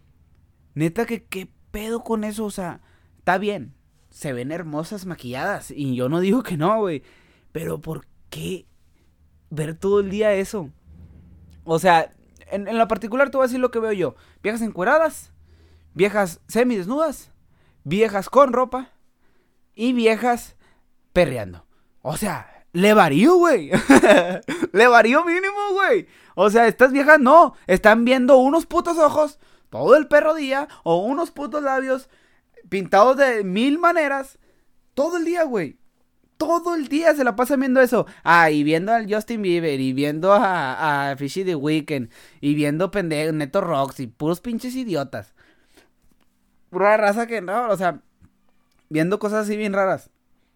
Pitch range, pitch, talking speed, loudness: 155-255 Hz, 205 Hz, 155 wpm, -19 LUFS